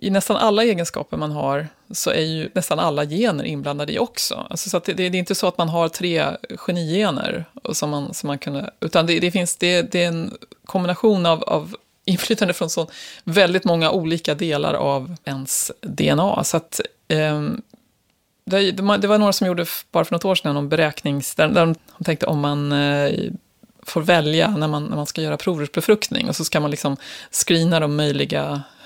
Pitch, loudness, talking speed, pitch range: 170 Hz, -20 LUFS, 185 wpm, 150-195 Hz